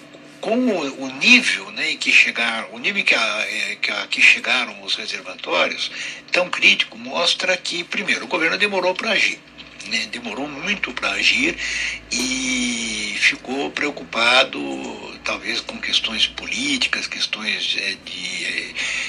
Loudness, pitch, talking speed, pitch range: -19 LUFS, 225 Hz, 130 wpm, 175-255 Hz